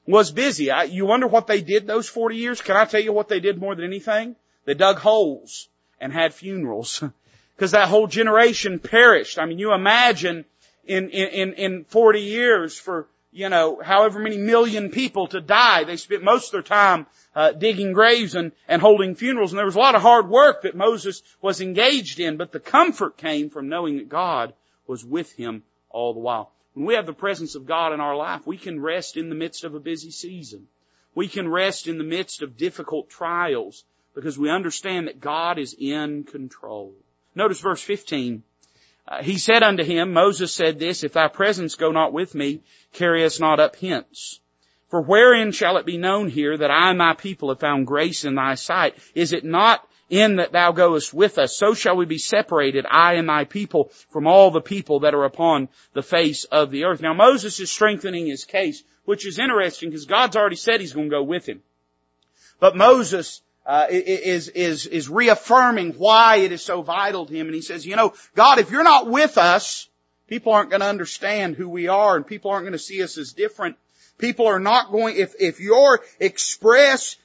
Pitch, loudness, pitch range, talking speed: 180 Hz, -19 LUFS, 155-210 Hz, 205 wpm